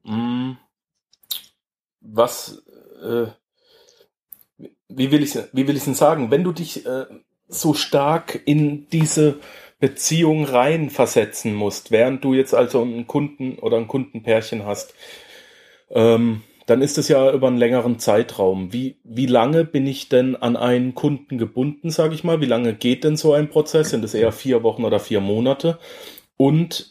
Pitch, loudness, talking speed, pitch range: 135 Hz, -19 LUFS, 155 wpm, 120-150 Hz